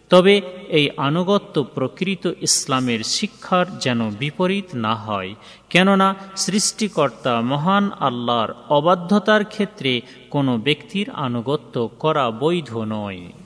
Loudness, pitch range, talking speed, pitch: -20 LUFS, 120-195 Hz, 100 wpm, 150 Hz